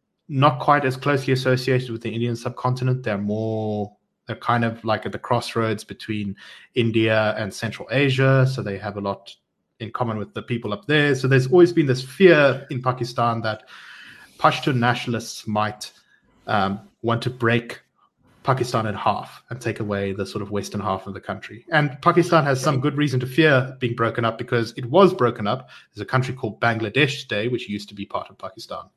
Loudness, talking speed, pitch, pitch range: -22 LUFS, 195 wpm, 120 Hz, 110-130 Hz